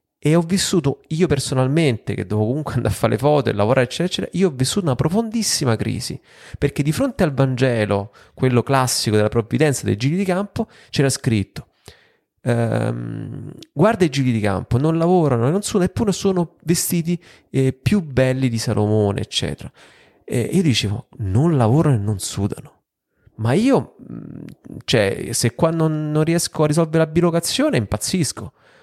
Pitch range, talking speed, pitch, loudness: 120-170 Hz, 165 wpm, 140 Hz, -19 LUFS